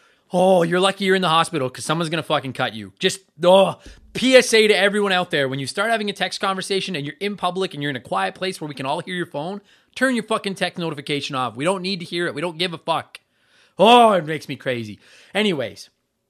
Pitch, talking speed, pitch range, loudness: 180 Hz, 250 wpm, 150-195 Hz, -20 LUFS